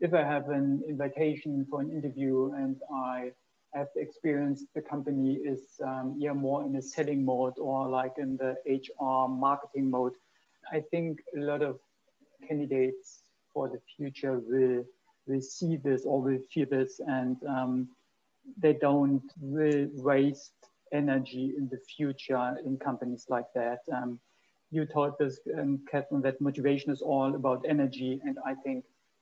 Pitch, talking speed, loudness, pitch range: 135 Hz, 155 wpm, -32 LUFS, 130-145 Hz